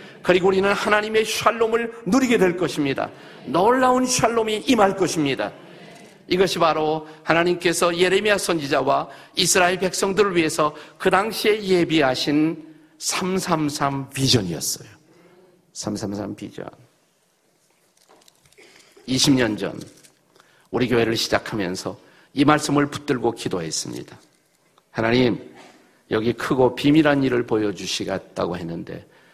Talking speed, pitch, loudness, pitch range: 255 characters per minute, 165 Hz, -21 LUFS, 135-190 Hz